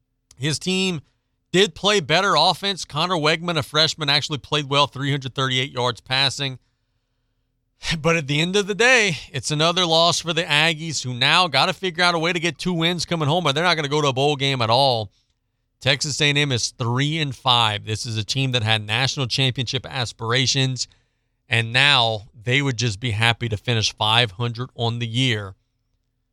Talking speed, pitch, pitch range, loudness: 195 wpm, 135 Hz, 120-155 Hz, -20 LUFS